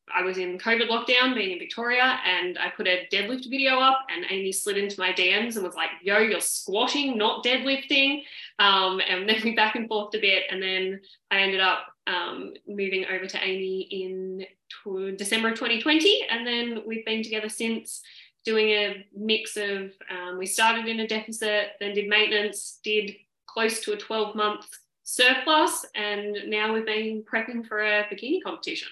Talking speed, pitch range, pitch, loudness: 185 wpm, 195-230 Hz, 215 Hz, -24 LUFS